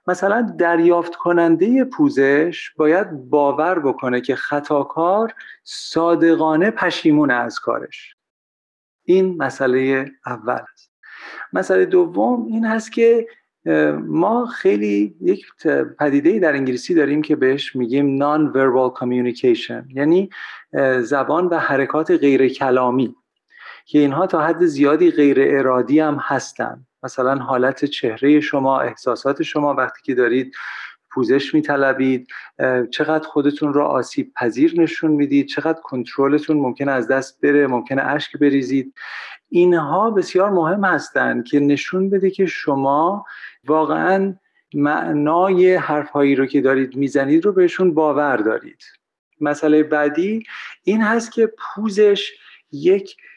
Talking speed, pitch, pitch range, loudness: 120 wpm, 150 Hz, 135-185 Hz, -18 LUFS